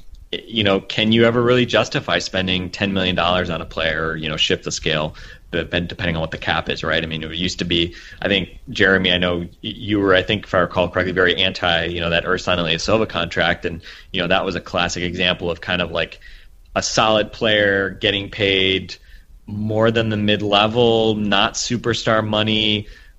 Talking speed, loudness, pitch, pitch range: 200 wpm, -18 LUFS, 95 Hz, 85-105 Hz